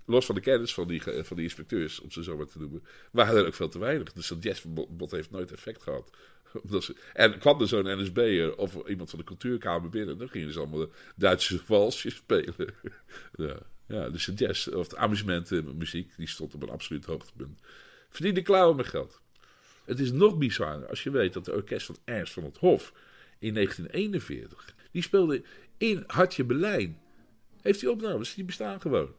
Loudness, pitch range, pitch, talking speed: -29 LUFS, 85-145 Hz, 110 Hz, 195 wpm